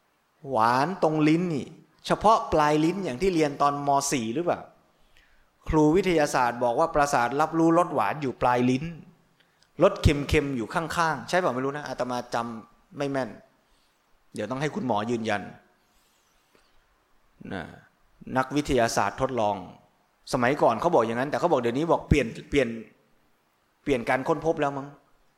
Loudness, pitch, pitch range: -25 LUFS, 145 Hz, 125-165 Hz